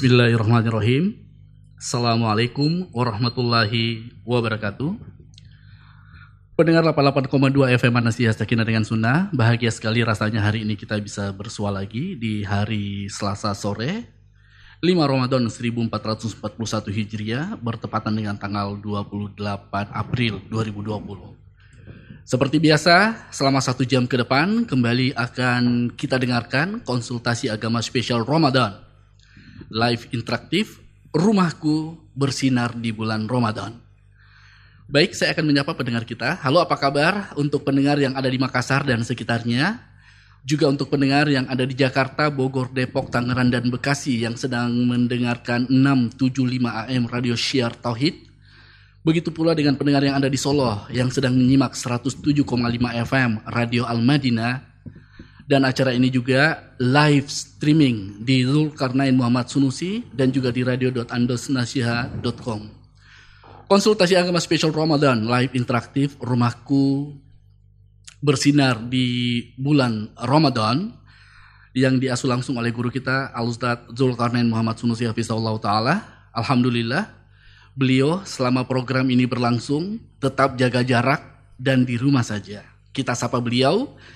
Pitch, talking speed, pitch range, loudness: 125 Hz, 115 wpm, 115-135 Hz, -21 LUFS